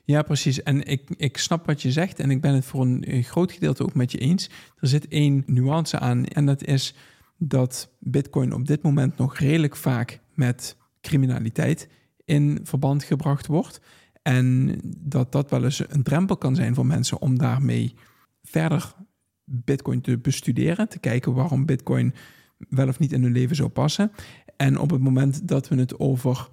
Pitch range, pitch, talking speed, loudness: 130-150 Hz, 140 Hz, 180 wpm, -23 LUFS